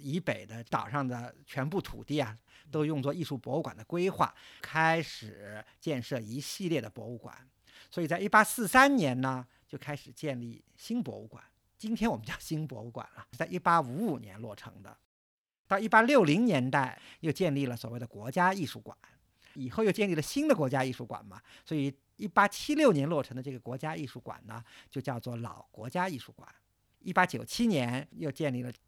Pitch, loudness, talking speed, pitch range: 140 Hz, -31 LUFS, 290 characters per minute, 120-180 Hz